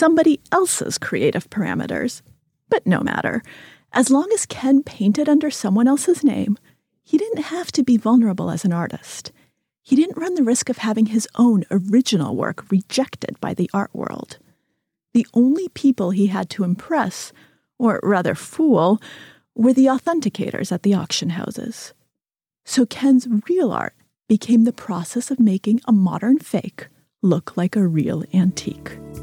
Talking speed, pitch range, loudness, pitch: 155 wpm, 200-275 Hz, -19 LUFS, 235 Hz